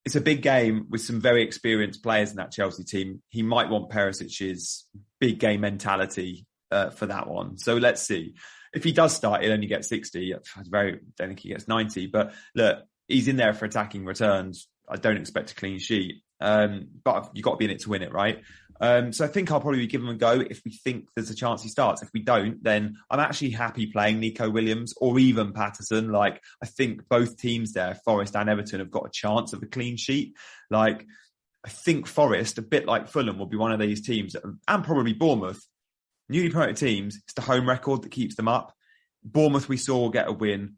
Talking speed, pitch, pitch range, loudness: 220 wpm, 110 Hz, 105-125 Hz, -26 LUFS